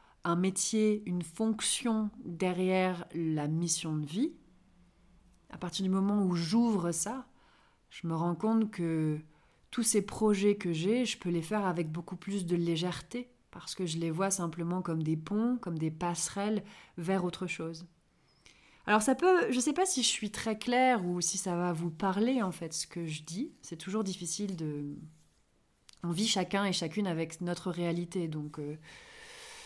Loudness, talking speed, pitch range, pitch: -32 LUFS, 180 wpm, 170-215 Hz, 185 Hz